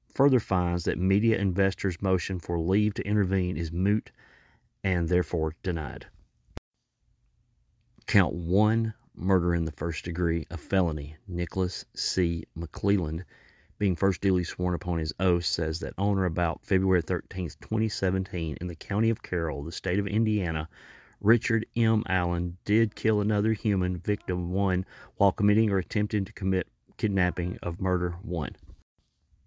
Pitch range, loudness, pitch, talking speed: 85-100 Hz, -28 LUFS, 95 Hz, 145 wpm